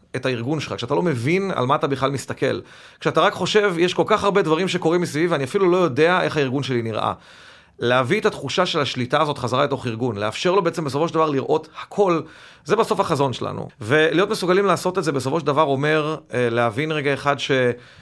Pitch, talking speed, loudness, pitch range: 155 Hz, 210 wpm, -20 LUFS, 135-180 Hz